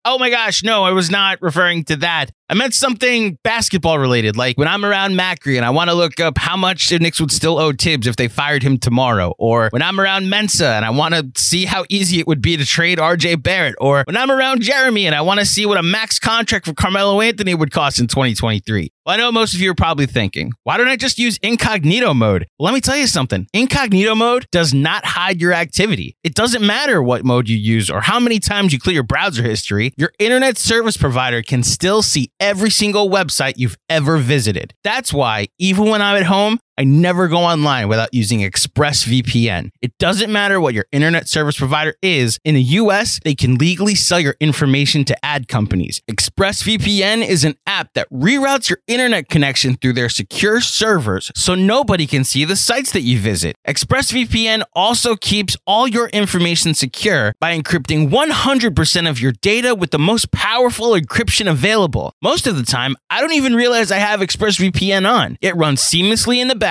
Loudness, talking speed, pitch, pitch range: -14 LUFS, 210 wpm, 170 Hz, 135-210 Hz